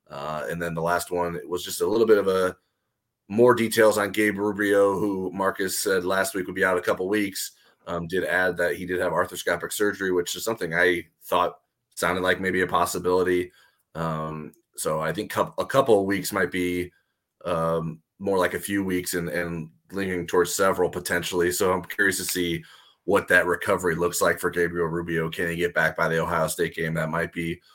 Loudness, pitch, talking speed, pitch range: -24 LUFS, 90 Hz, 210 wpm, 85-95 Hz